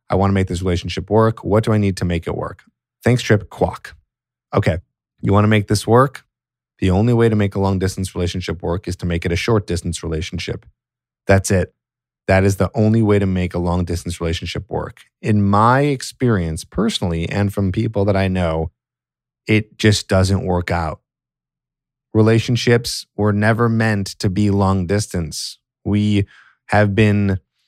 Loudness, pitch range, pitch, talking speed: -18 LUFS, 90-110 Hz, 100 Hz, 180 wpm